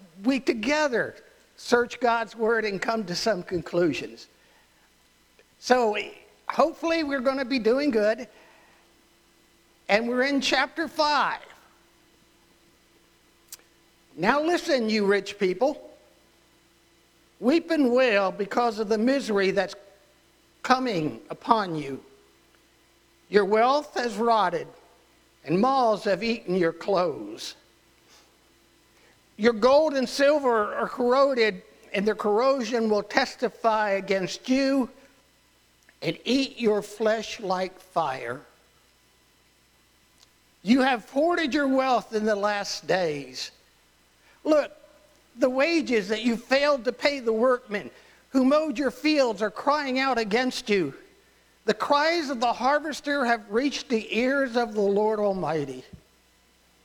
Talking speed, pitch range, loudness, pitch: 115 wpm, 200-270 Hz, -25 LUFS, 230 Hz